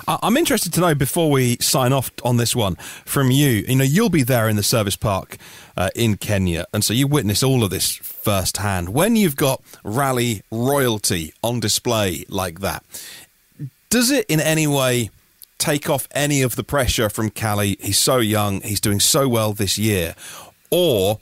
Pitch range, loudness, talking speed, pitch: 100-140 Hz, -19 LUFS, 185 wpm, 115 Hz